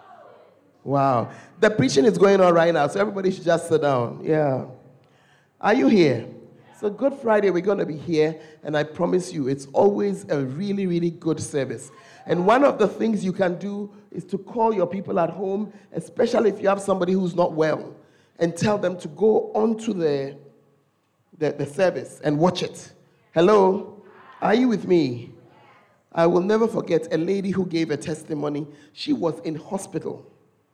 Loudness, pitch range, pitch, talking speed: -22 LUFS, 155-200 Hz, 175 Hz, 180 wpm